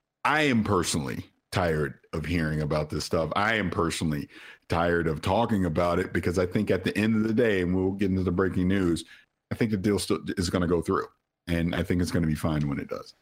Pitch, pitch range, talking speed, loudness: 90 Hz, 85-95 Hz, 245 wpm, -27 LUFS